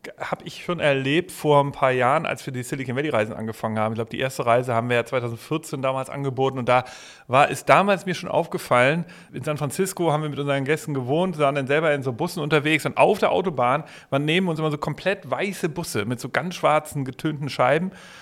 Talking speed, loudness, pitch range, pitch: 225 wpm, -23 LUFS, 130-160 Hz, 145 Hz